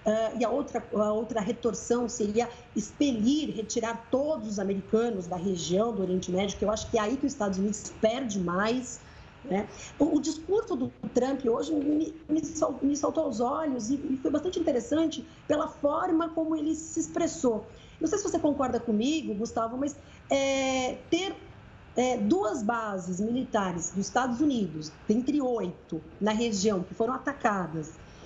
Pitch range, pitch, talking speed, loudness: 215-295 Hz, 245 Hz, 170 wpm, -29 LUFS